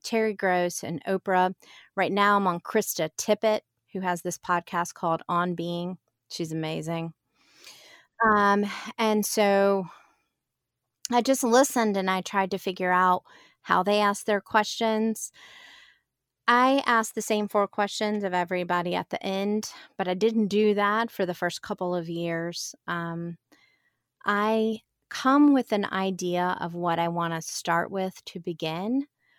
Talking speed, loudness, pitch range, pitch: 150 wpm, -26 LUFS, 175-215 Hz, 195 Hz